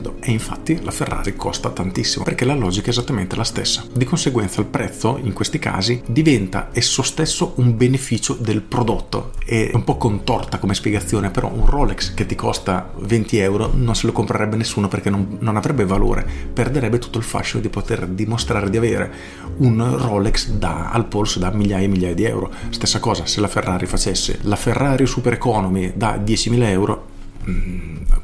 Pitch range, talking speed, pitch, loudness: 95-120 Hz, 180 wpm, 110 Hz, -19 LUFS